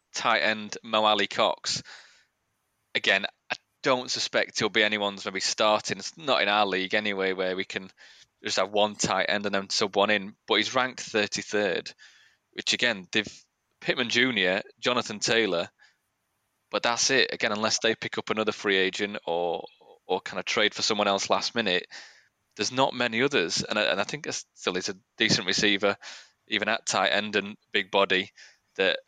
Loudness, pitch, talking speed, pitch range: -26 LUFS, 100 Hz, 190 wpm, 95-105 Hz